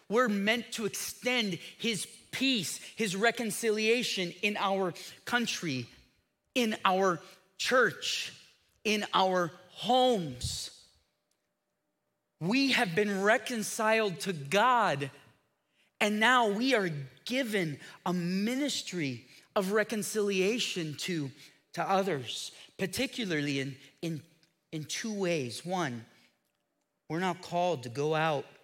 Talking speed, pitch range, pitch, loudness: 100 wpm, 160-220 Hz, 195 Hz, -31 LUFS